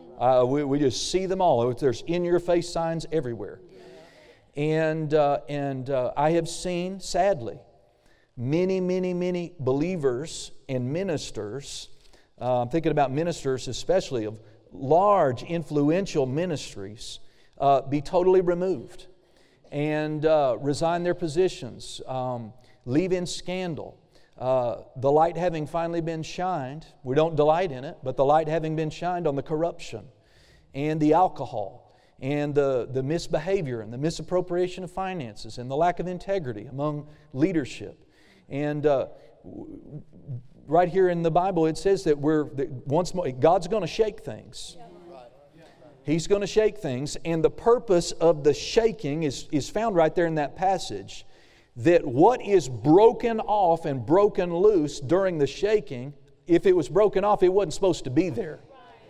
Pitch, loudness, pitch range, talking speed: 155 Hz, -25 LUFS, 135-180 Hz, 150 wpm